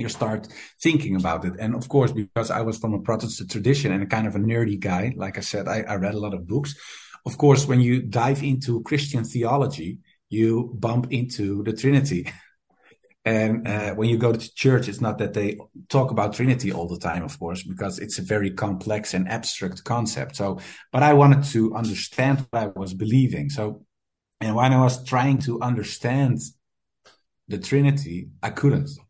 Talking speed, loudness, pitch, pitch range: 195 wpm, -23 LUFS, 115 Hz, 105-130 Hz